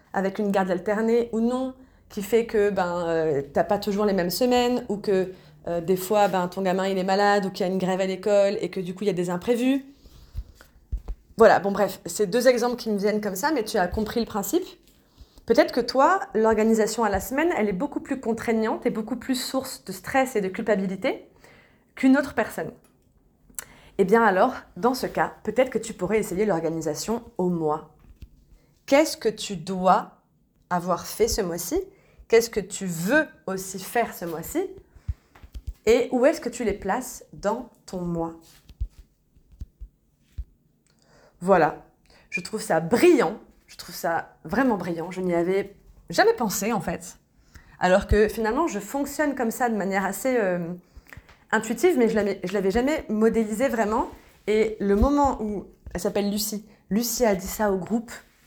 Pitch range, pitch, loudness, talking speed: 190-240 Hz, 210 Hz, -24 LUFS, 180 wpm